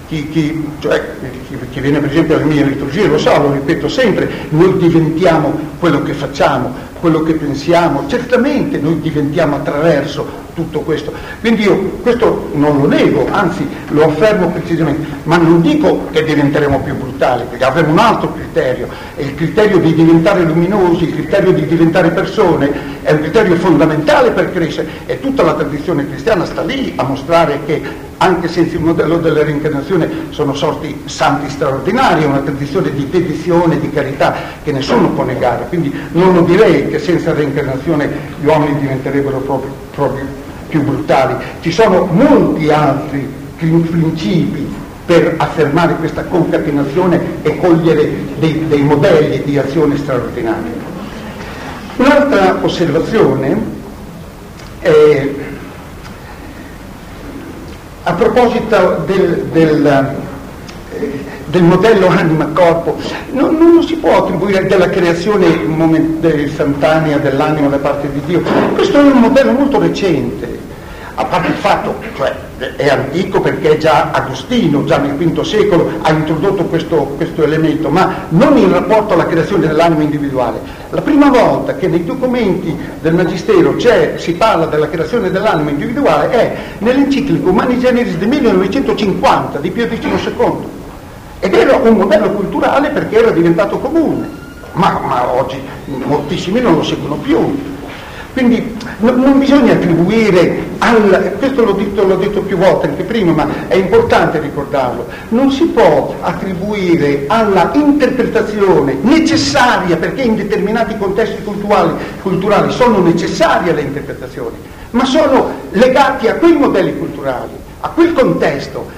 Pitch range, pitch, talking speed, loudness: 150-200 Hz, 165 Hz, 140 wpm, -12 LUFS